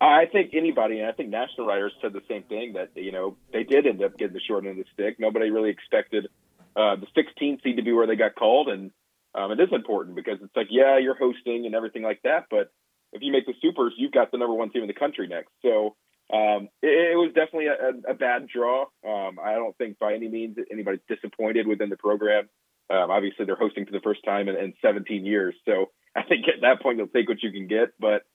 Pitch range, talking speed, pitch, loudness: 105-170 Hz, 250 wpm, 120 Hz, -25 LUFS